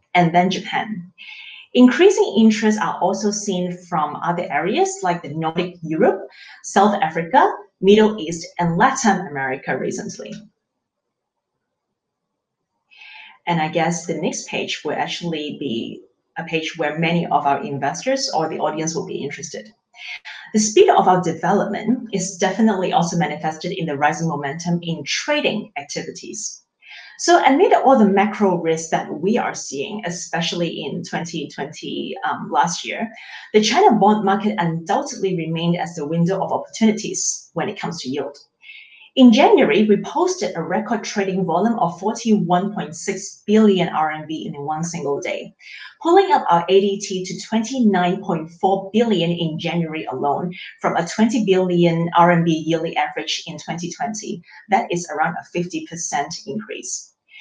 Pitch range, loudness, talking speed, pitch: 165-210 Hz, -19 LUFS, 140 wpm, 185 Hz